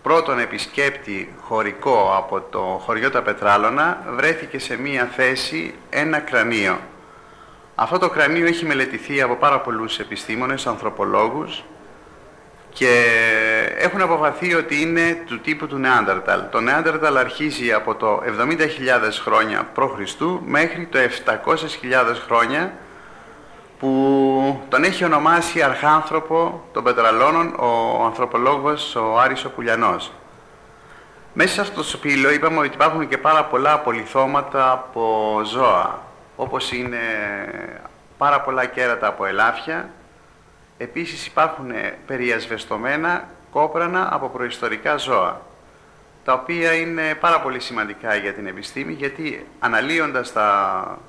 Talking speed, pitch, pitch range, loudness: 115 wpm, 140 Hz, 125-160 Hz, -19 LUFS